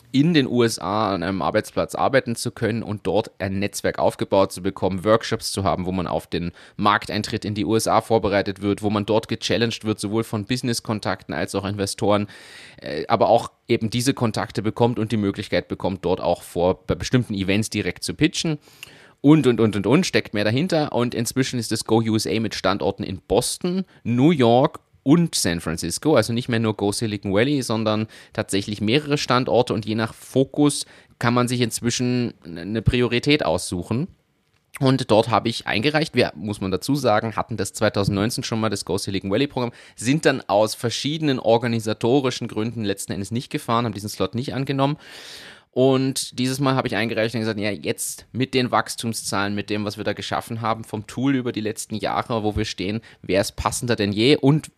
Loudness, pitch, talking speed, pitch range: -22 LUFS, 115 Hz, 190 wpm, 105-125 Hz